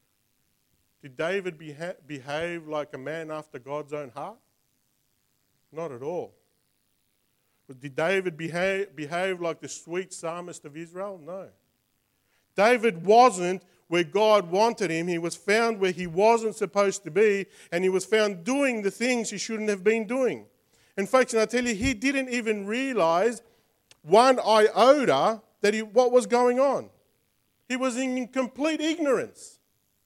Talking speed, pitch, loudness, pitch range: 150 wpm, 205 Hz, -25 LUFS, 170-240 Hz